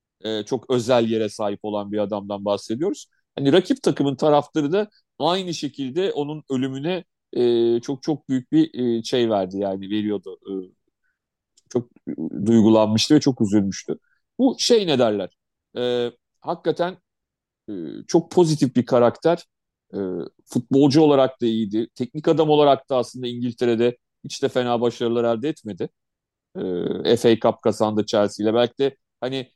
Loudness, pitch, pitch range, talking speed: -21 LUFS, 125 Hz, 110-150 Hz, 125 wpm